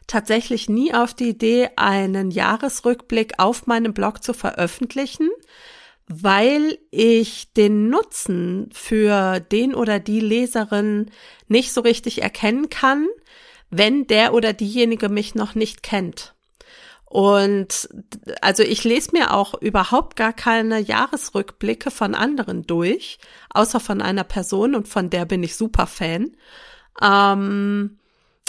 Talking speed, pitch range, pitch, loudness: 125 wpm, 205-245 Hz, 220 Hz, -19 LUFS